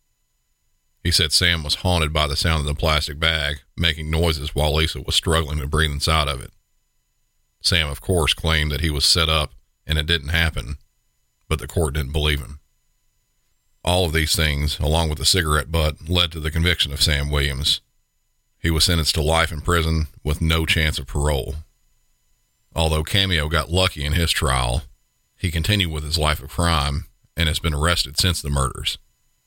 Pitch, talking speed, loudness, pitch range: 80 Hz, 185 wpm, -20 LUFS, 75-85 Hz